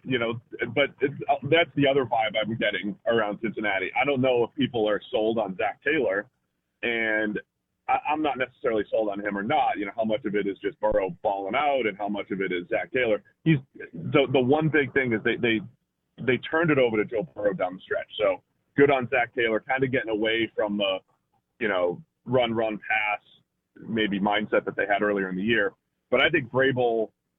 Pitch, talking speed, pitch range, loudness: 110 Hz, 220 wpm, 105-130 Hz, -25 LUFS